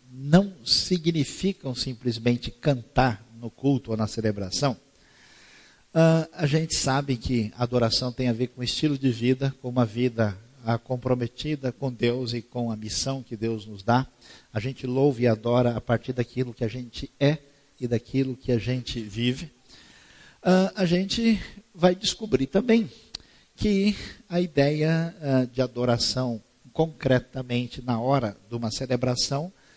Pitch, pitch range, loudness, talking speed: 130 Hz, 120-145 Hz, -26 LUFS, 145 wpm